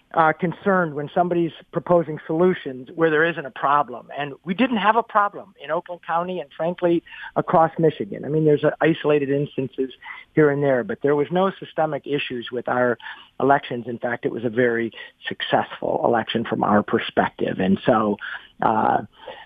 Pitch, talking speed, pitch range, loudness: 150 Hz, 175 wpm, 135-170 Hz, -22 LUFS